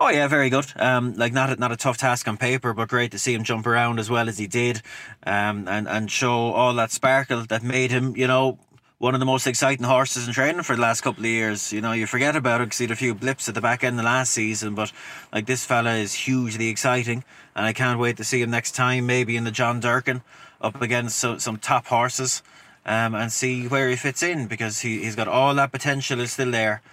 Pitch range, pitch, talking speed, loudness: 115-130 Hz, 120 Hz, 260 wpm, -22 LUFS